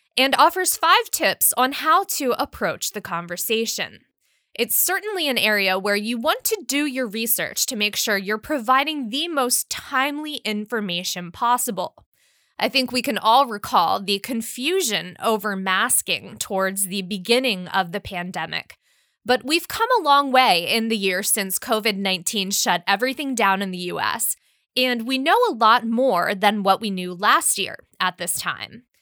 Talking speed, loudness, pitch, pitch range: 165 wpm, -20 LUFS, 230 Hz, 200-275 Hz